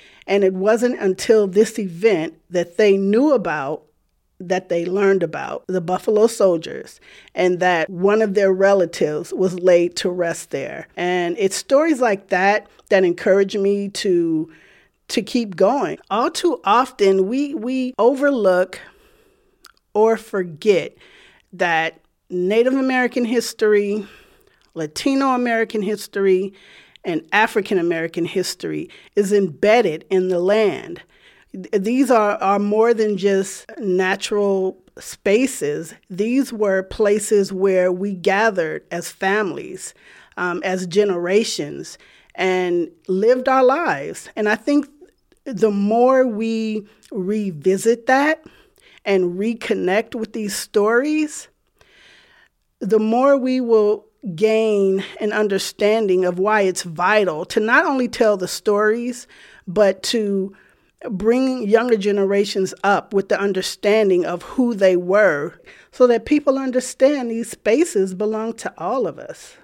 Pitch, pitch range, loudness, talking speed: 210 Hz, 190-240 Hz, -19 LUFS, 120 wpm